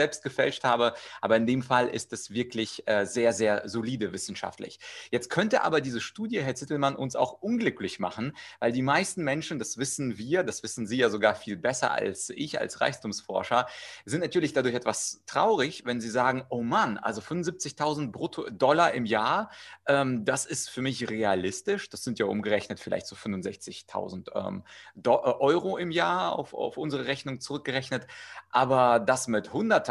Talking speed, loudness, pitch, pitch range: 175 wpm, -28 LUFS, 125 Hz, 115-140 Hz